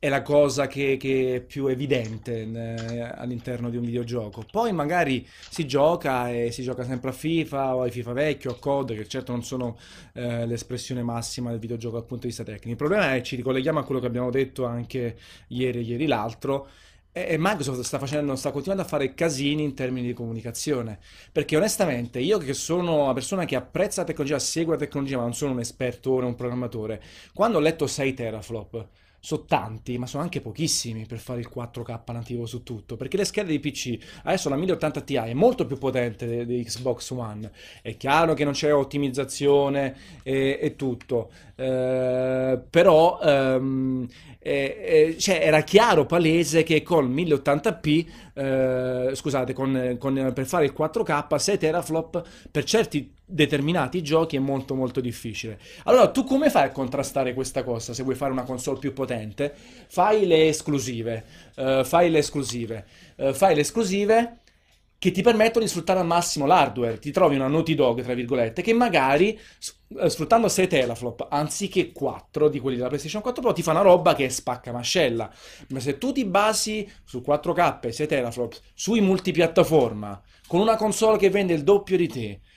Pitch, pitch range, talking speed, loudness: 135 Hz, 125-160 Hz, 180 wpm, -24 LUFS